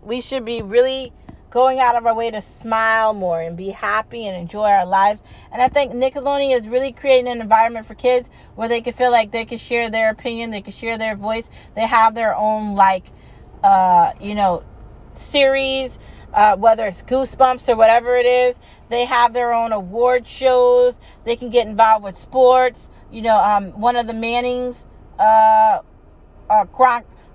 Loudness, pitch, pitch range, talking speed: -17 LUFS, 235 Hz, 220-250 Hz, 185 wpm